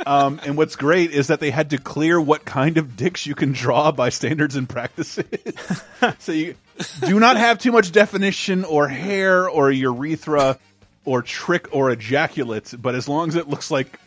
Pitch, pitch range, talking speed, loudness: 150 Hz, 135-170 Hz, 190 wpm, -19 LUFS